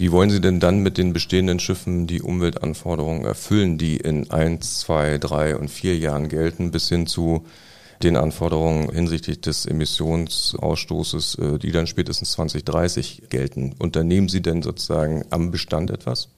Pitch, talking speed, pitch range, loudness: 80 Hz, 150 wpm, 75-90 Hz, -22 LUFS